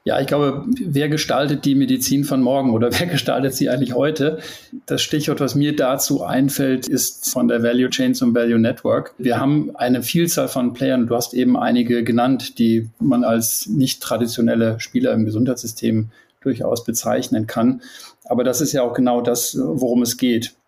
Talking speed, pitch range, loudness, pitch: 175 wpm, 120-145 Hz, -19 LUFS, 125 Hz